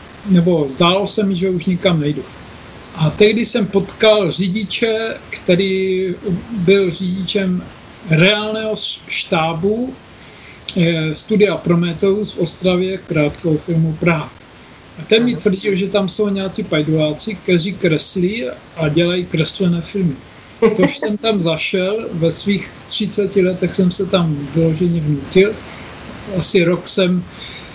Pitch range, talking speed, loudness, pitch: 165-200 Hz, 125 wpm, -16 LUFS, 185 Hz